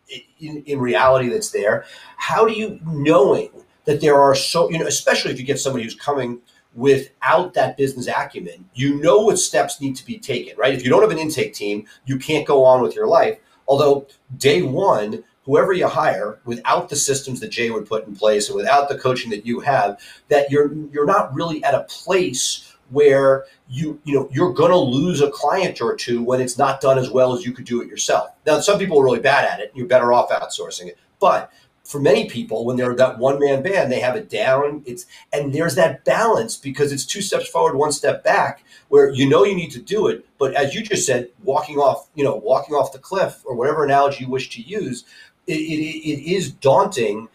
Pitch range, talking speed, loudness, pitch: 130-155 Hz, 225 wpm, -18 LUFS, 140 Hz